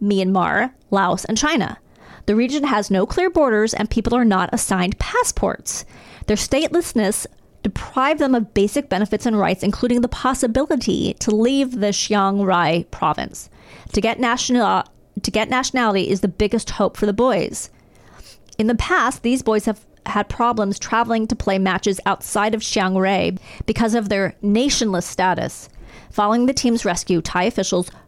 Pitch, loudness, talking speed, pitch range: 215 Hz, -19 LUFS, 160 wpm, 195-240 Hz